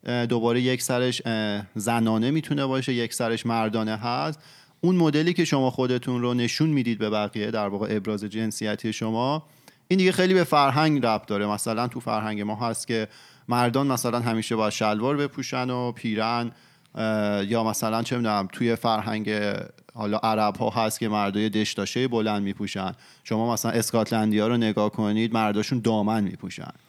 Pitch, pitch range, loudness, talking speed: 115 Hz, 110-125 Hz, -25 LUFS, 160 wpm